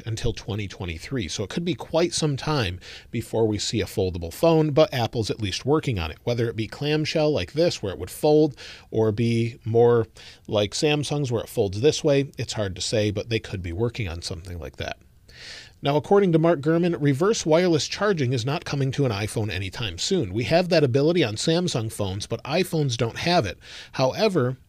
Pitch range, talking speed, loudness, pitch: 105-155 Hz, 205 wpm, -24 LUFS, 120 Hz